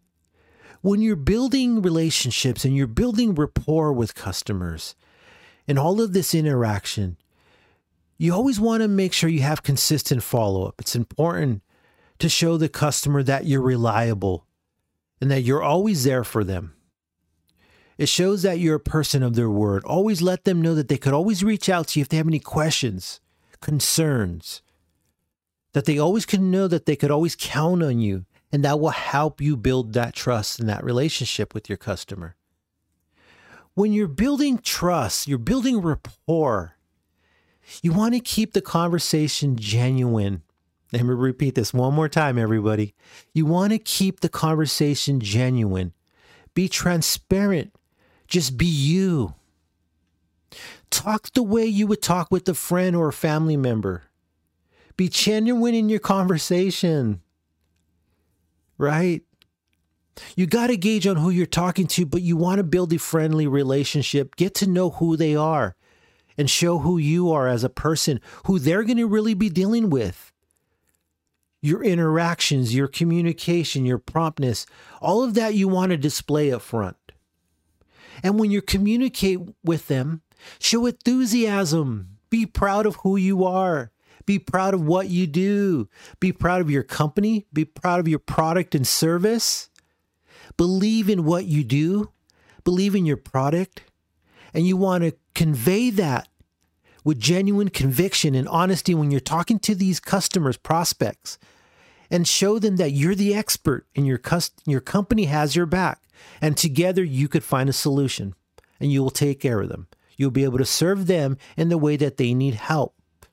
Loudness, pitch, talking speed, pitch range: -22 LUFS, 150 Hz, 160 wpm, 115-185 Hz